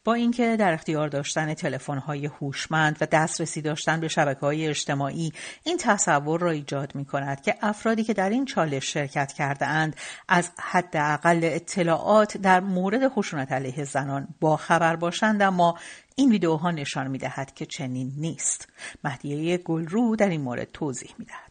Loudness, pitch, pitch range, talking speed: -25 LUFS, 160 Hz, 145-185 Hz, 150 wpm